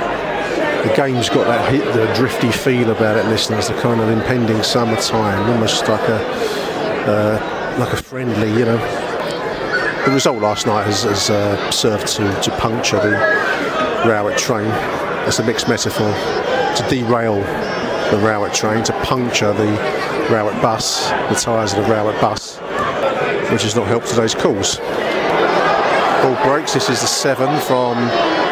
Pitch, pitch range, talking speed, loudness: 110 Hz, 105-120 Hz, 160 wpm, -16 LUFS